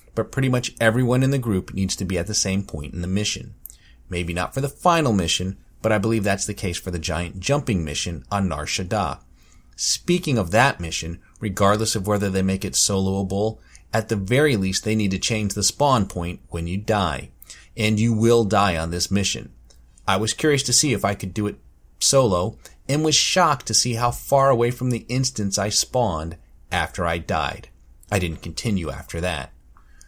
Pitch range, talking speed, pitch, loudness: 85-115 Hz, 200 wpm, 100 Hz, -22 LUFS